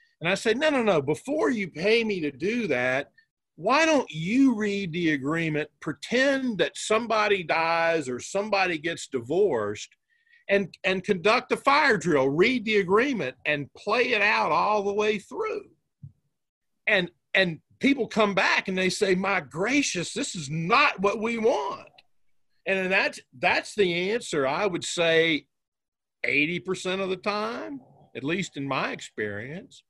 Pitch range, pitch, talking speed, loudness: 170-230 Hz, 200 Hz, 155 wpm, -25 LUFS